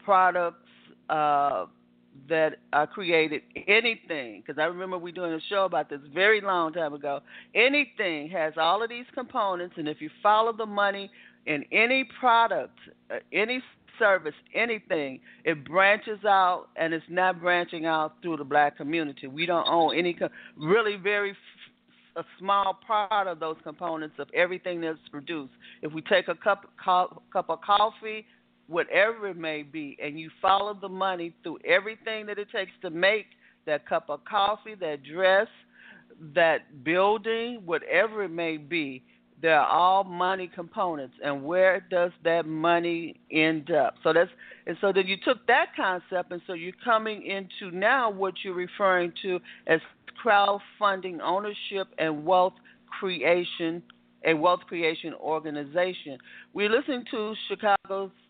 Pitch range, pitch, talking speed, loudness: 160-205 Hz, 180 Hz, 155 wpm, -26 LUFS